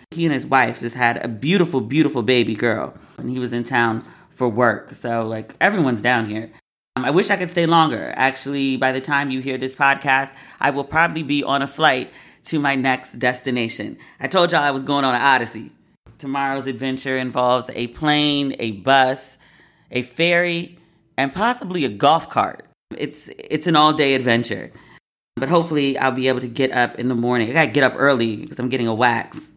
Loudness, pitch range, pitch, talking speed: -19 LUFS, 125-150 Hz, 135 Hz, 205 wpm